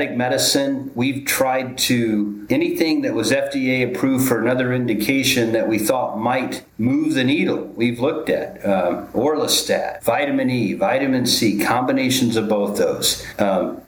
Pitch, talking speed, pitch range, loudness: 130 Hz, 145 wpm, 120-135 Hz, -19 LUFS